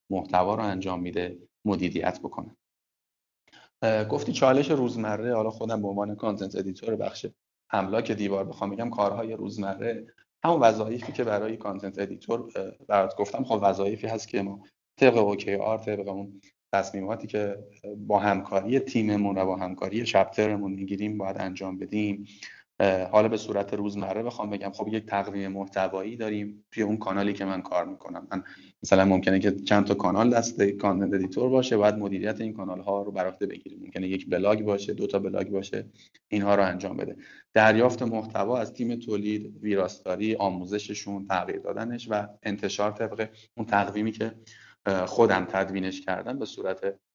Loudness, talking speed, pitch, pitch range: -27 LUFS, 155 wpm, 100 Hz, 95-110 Hz